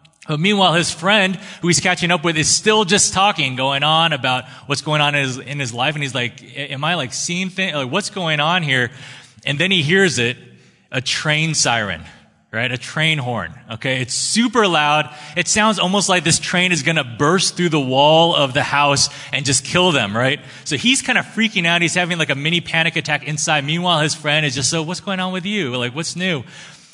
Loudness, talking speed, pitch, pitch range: -17 LUFS, 225 wpm, 155 Hz, 140-180 Hz